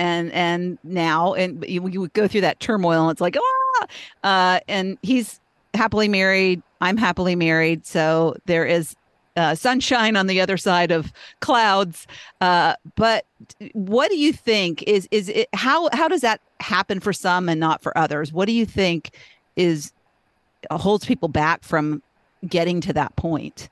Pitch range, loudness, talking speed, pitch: 165-210 Hz, -20 LUFS, 165 wpm, 180 Hz